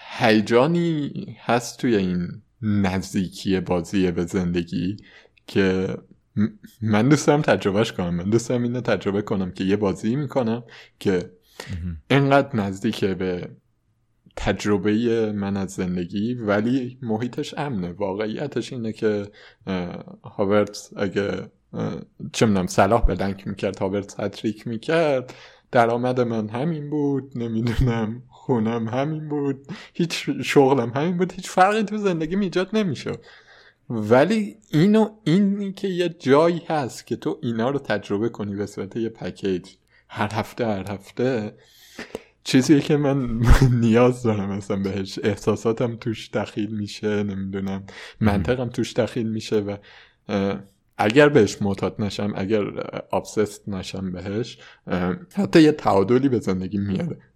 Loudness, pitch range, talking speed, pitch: -23 LUFS, 100-135 Hz, 120 wpm, 110 Hz